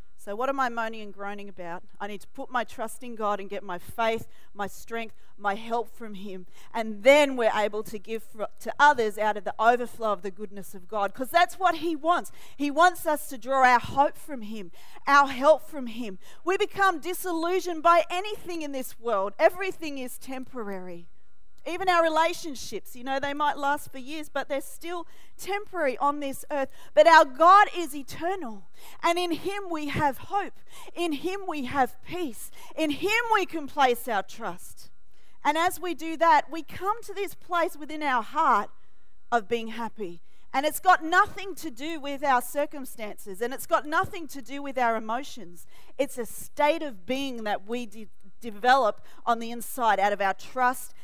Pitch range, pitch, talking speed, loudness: 225-330 Hz, 275 Hz, 190 wpm, -26 LUFS